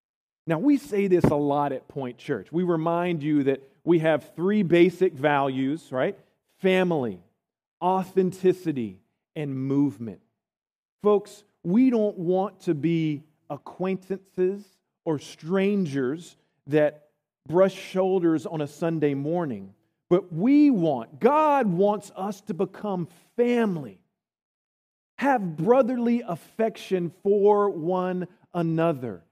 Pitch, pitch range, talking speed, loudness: 175 Hz, 150-195 Hz, 110 wpm, -25 LUFS